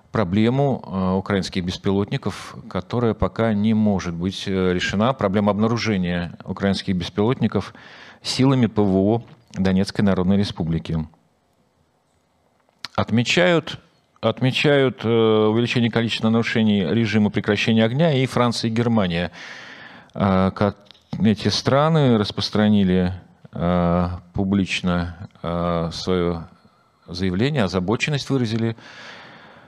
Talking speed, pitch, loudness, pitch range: 80 wpm, 105 Hz, -21 LUFS, 95-115 Hz